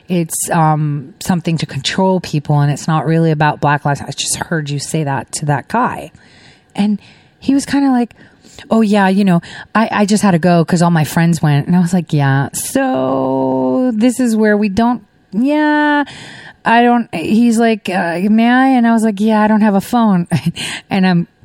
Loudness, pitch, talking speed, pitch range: -14 LUFS, 180 Hz, 205 wpm, 150-225 Hz